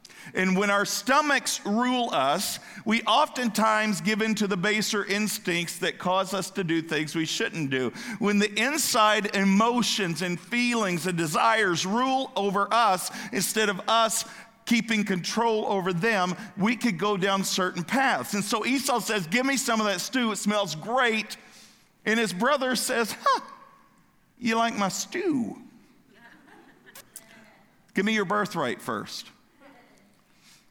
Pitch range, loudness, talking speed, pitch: 195-235 Hz, -25 LUFS, 145 wpm, 215 Hz